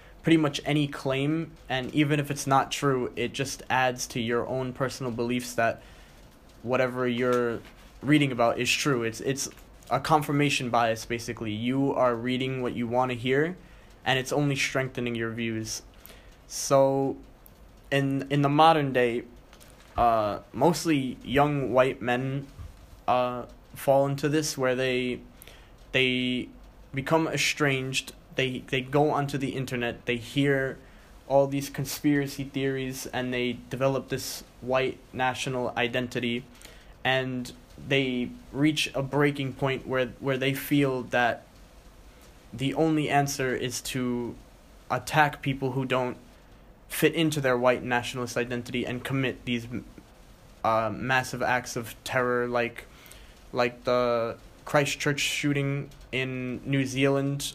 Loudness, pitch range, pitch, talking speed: -27 LUFS, 125-140 Hz, 130 Hz, 130 wpm